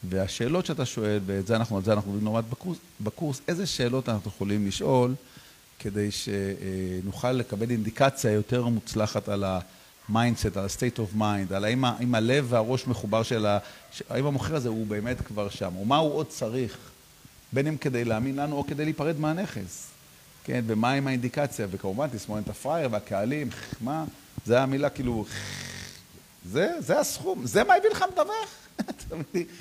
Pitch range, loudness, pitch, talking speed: 105-135 Hz, -28 LUFS, 120 Hz, 160 wpm